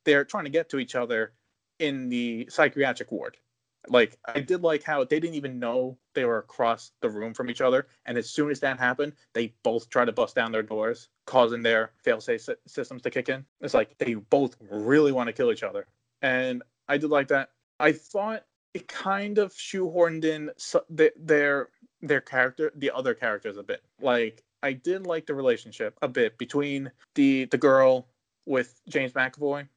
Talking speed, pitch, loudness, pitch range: 190 wpm, 140 Hz, -26 LUFS, 125-165 Hz